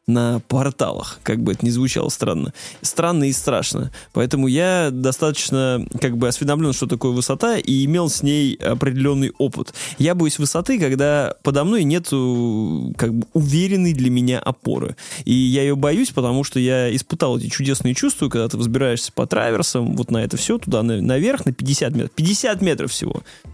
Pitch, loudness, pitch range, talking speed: 135 Hz, -19 LUFS, 125-150 Hz, 170 wpm